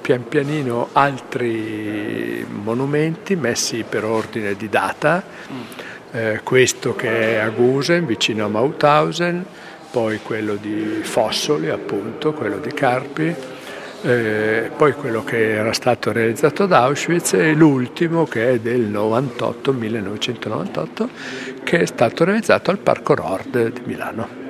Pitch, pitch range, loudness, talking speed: 120 Hz, 110-155 Hz, -19 LUFS, 125 wpm